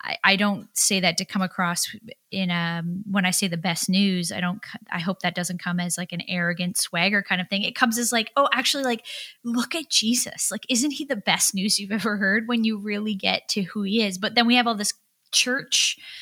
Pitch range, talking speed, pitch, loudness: 180-235 Hz, 235 wpm, 200 Hz, -23 LUFS